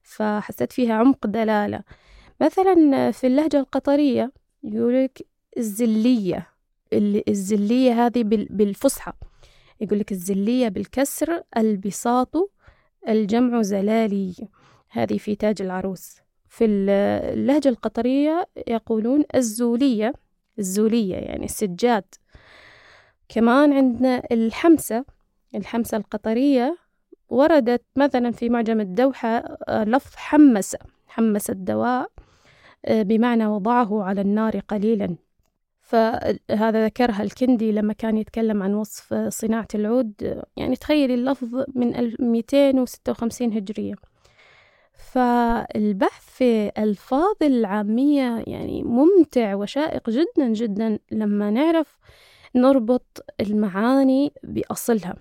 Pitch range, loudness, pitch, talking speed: 215-265 Hz, -21 LUFS, 235 Hz, 90 wpm